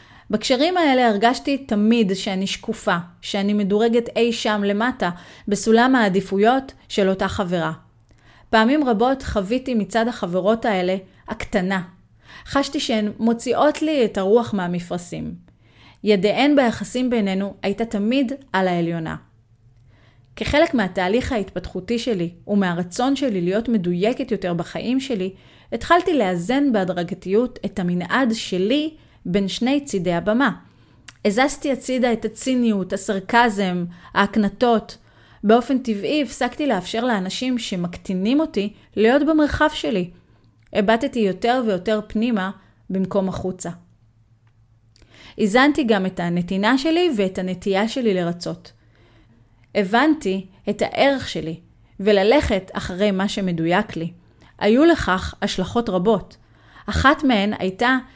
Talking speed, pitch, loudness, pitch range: 110 wpm, 210 Hz, -20 LUFS, 185-240 Hz